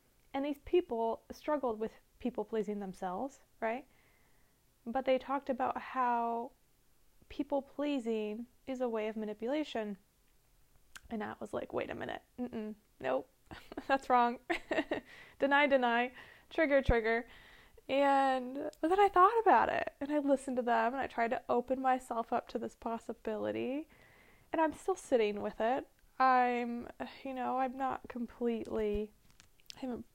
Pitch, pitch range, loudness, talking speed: 255 Hz, 230-280 Hz, -34 LUFS, 140 wpm